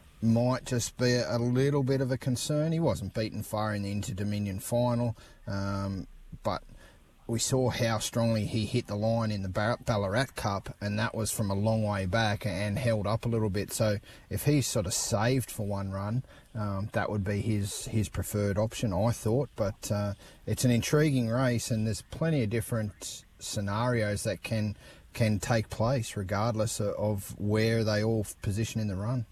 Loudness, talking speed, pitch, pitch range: -30 LUFS, 185 wpm, 110 Hz, 105-120 Hz